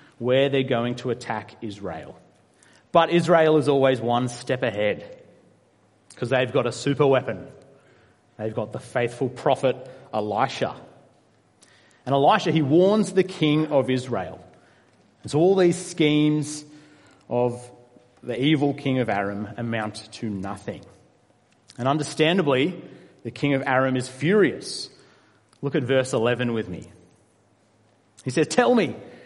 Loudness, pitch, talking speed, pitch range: -23 LUFS, 130 Hz, 135 wpm, 115-150 Hz